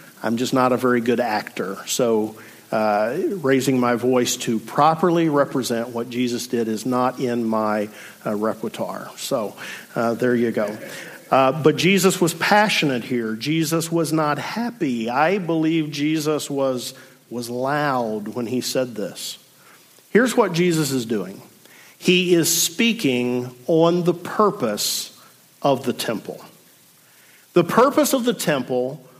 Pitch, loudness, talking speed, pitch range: 130 Hz, -21 LUFS, 140 wpm, 120-165 Hz